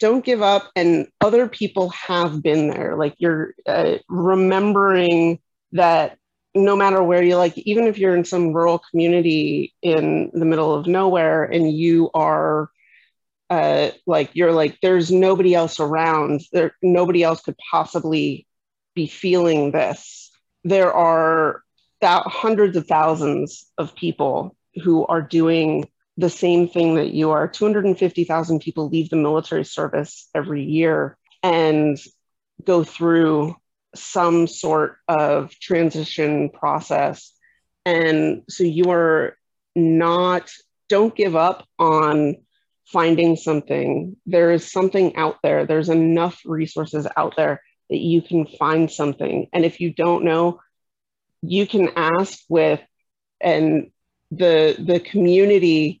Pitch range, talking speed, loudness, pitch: 160-180 Hz, 130 wpm, -19 LUFS, 170 Hz